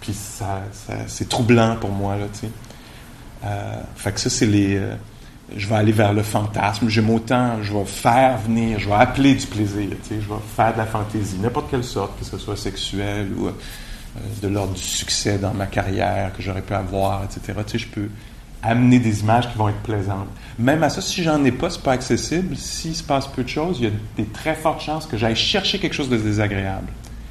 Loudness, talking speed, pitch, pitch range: -21 LUFS, 230 wpm, 110 Hz, 100-125 Hz